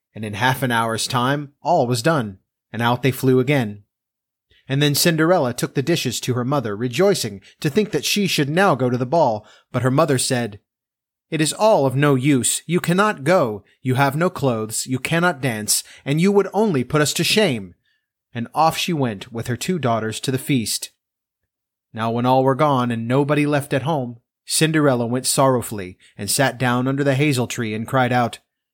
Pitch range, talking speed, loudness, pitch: 120-150 Hz, 200 wpm, -19 LUFS, 130 Hz